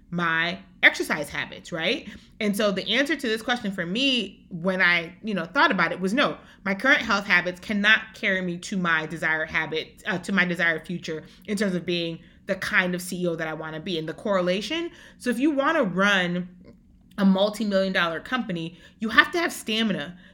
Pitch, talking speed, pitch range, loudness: 190 Hz, 205 wpm, 175-220 Hz, -24 LUFS